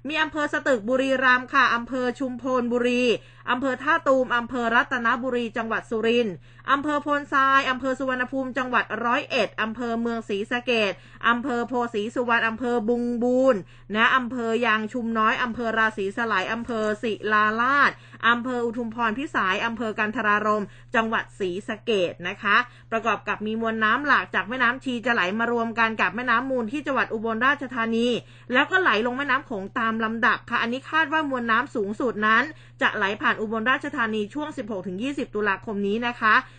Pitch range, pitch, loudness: 220-255 Hz, 235 Hz, -23 LUFS